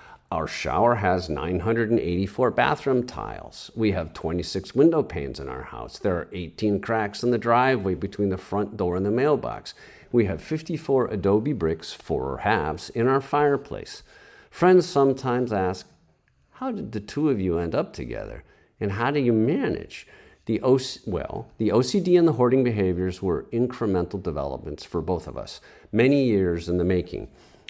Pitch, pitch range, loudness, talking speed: 110 Hz, 90-130 Hz, -24 LUFS, 165 wpm